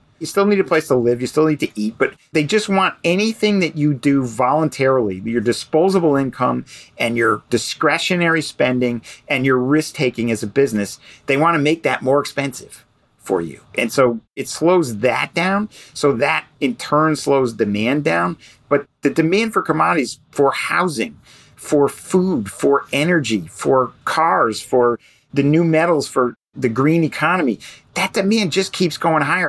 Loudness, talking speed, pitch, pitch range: -18 LUFS, 170 wpm, 145 Hz, 125-165 Hz